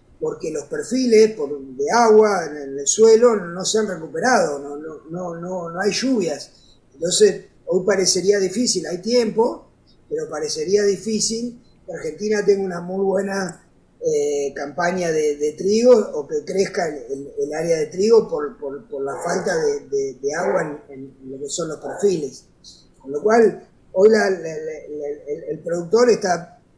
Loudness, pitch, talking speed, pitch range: -20 LUFS, 205 Hz, 170 wpm, 170-260 Hz